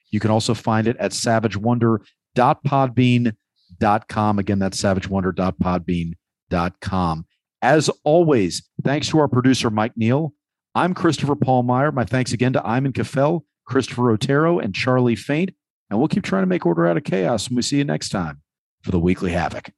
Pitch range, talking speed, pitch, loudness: 100-135 Hz, 165 wpm, 120 Hz, -20 LUFS